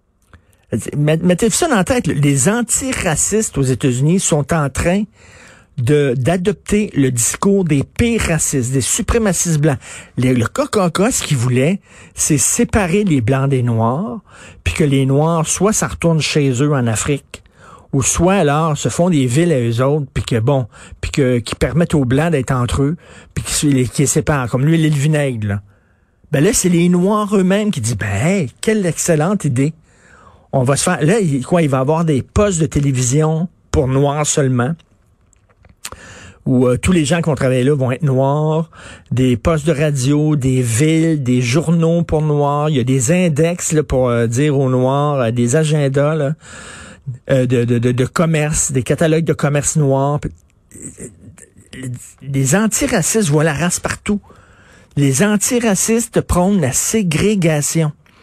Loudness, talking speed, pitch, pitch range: -15 LUFS, 170 wpm, 145 Hz, 130-170 Hz